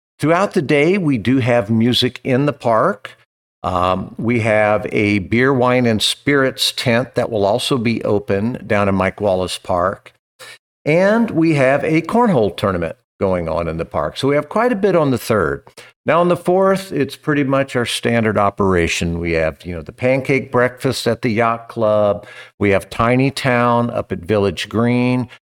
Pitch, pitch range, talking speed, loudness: 120 Hz, 105-140 Hz, 185 wpm, -17 LUFS